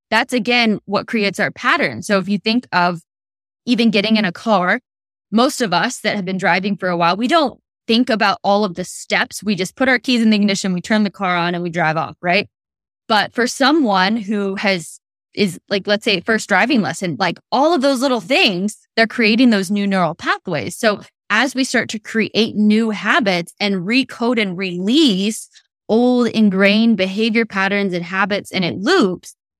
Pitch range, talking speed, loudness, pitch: 190-235 Hz, 195 wpm, -17 LUFS, 210 Hz